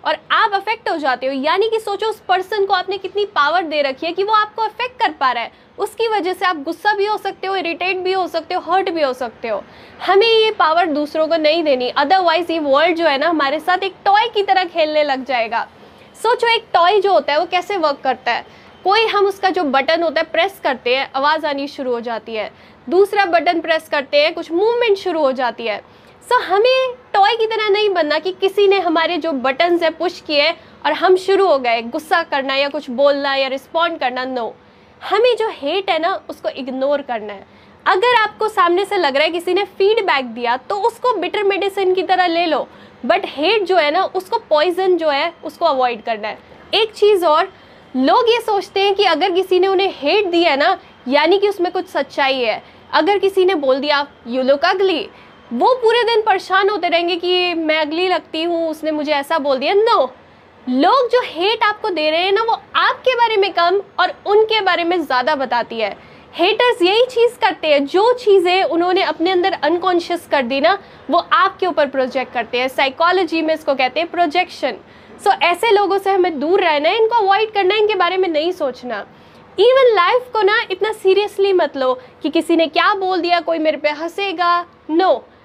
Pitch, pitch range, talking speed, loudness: 350 Hz, 300-395 Hz, 215 wpm, -16 LUFS